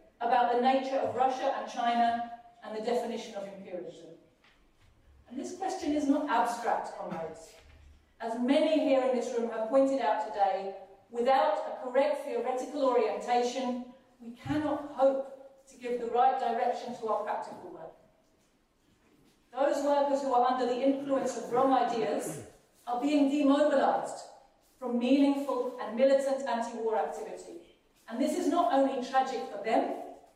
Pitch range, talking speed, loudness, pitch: 235-270 Hz, 145 wpm, -30 LUFS, 250 Hz